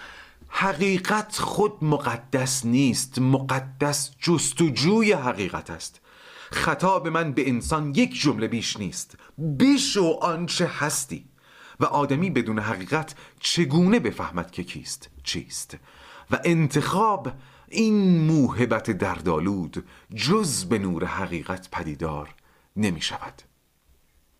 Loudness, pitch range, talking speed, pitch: -24 LUFS, 110-170 Hz, 100 wpm, 140 Hz